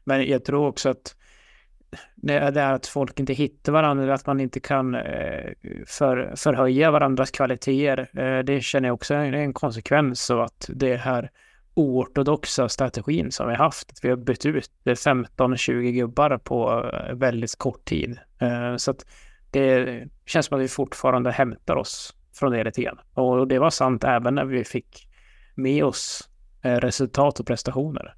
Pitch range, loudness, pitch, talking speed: 125-140 Hz, -23 LUFS, 130 Hz, 160 wpm